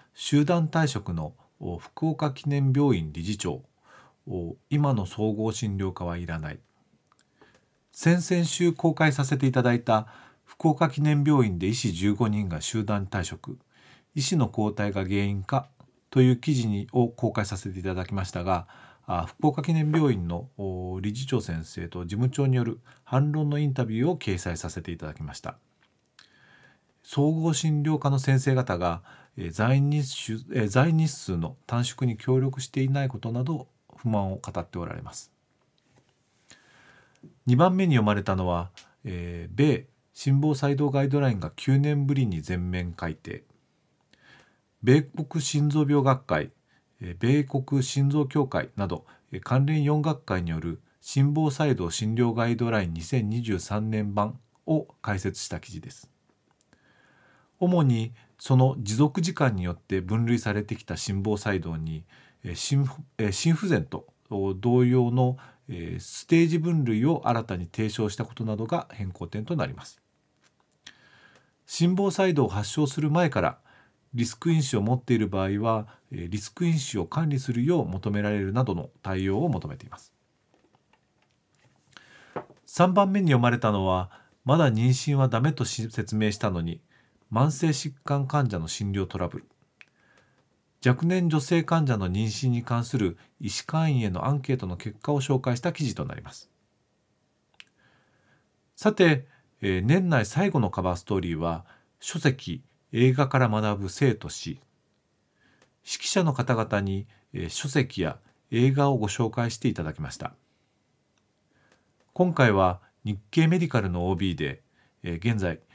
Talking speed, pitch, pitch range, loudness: 255 characters per minute, 120 Hz, 100-145 Hz, -26 LUFS